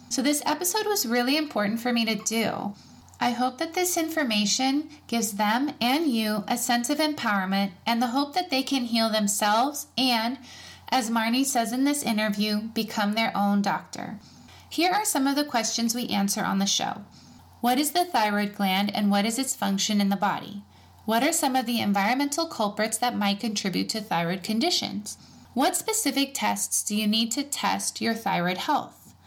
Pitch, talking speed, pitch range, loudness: 230 Hz, 185 wpm, 205-275 Hz, -25 LUFS